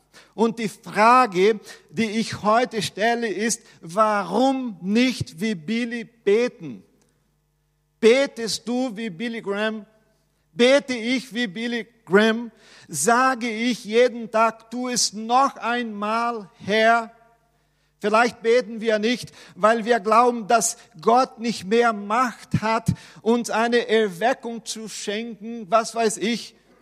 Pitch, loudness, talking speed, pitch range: 225 Hz, -22 LUFS, 120 wpm, 210-235 Hz